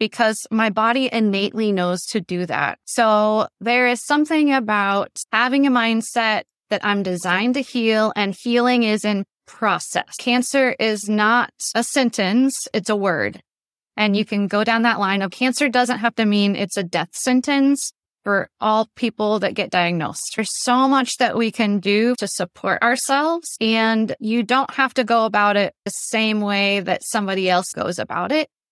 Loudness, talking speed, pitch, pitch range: -19 LUFS, 175 wpm, 220 Hz, 205-245 Hz